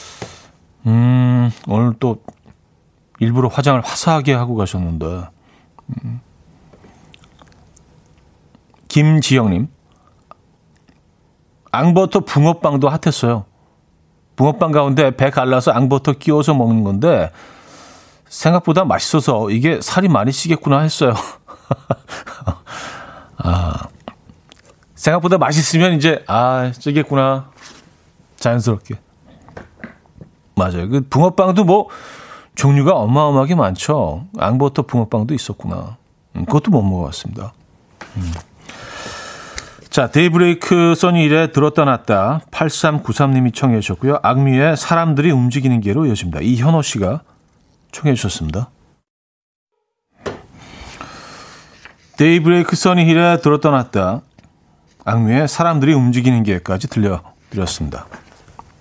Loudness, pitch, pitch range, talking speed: -15 LUFS, 135 Hz, 115-155 Hz, 235 characters per minute